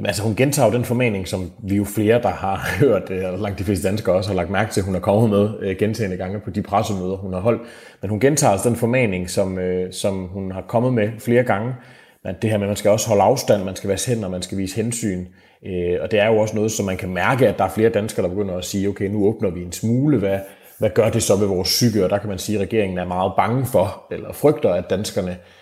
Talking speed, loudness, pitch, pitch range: 270 wpm, -20 LUFS, 100 Hz, 95-110 Hz